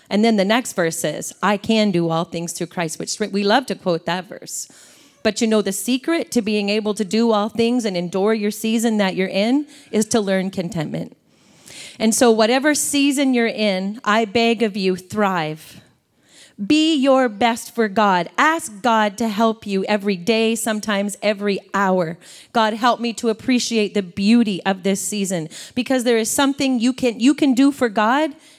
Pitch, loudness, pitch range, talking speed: 220 Hz, -19 LUFS, 195-240 Hz, 190 wpm